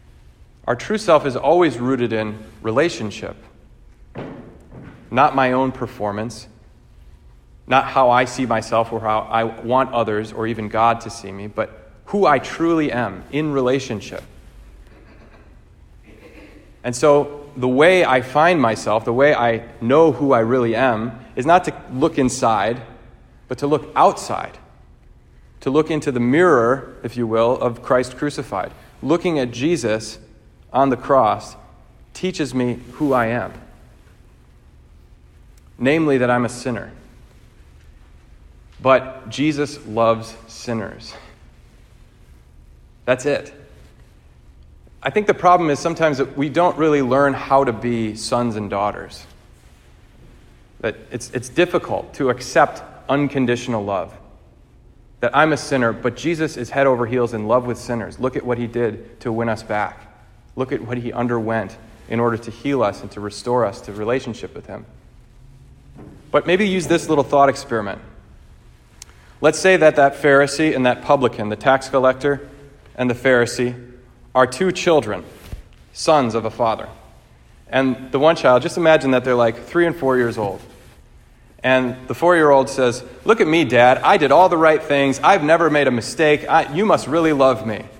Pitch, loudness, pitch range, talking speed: 125 Hz, -18 LUFS, 115-145 Hz, 155 wpm